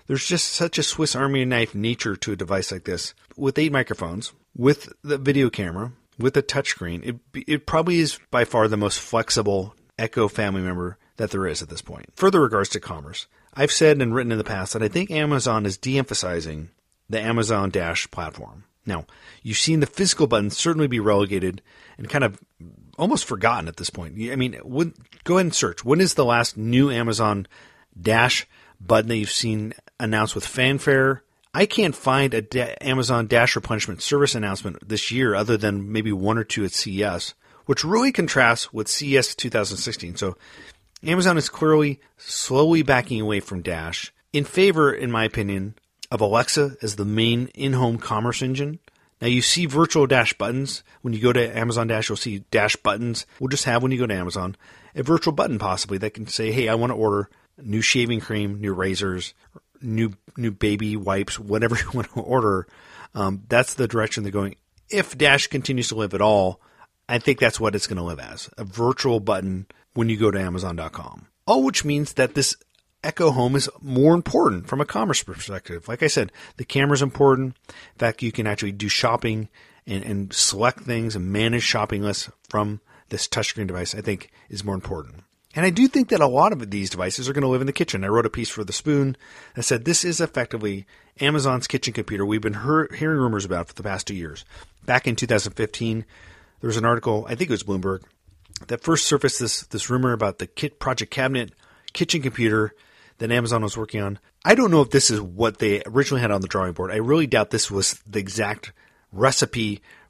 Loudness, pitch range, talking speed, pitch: -22 LUFS, 105-135 Hz, 200 wpm, 115 Hz